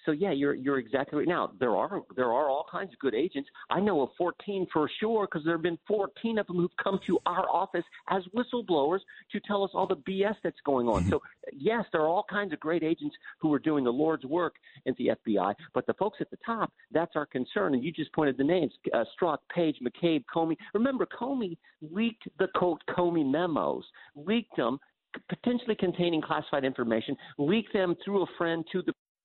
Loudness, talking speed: -30 LUFS, 215 wpm